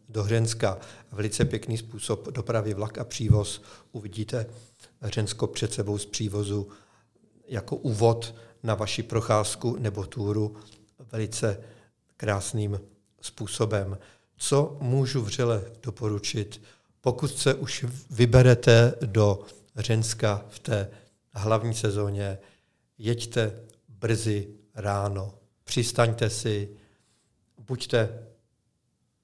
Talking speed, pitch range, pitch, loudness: 90 wpm, 105-120 Hz, 110 Hz, -27 LUFS